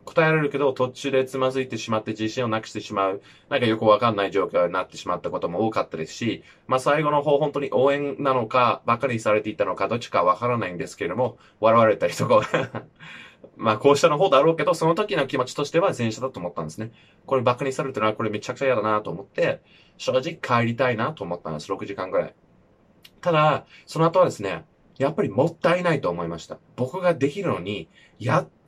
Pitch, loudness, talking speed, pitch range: 130 Hz, -23 LUFS, 460 characters per minute, 110-145 Hz